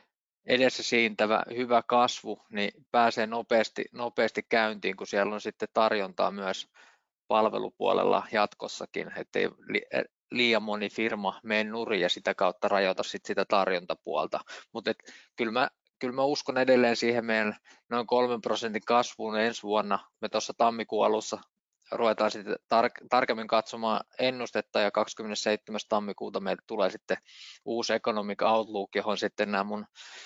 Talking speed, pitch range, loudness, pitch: 135 wpm, 105-120 Hz, -29 LUFS, 110 Hz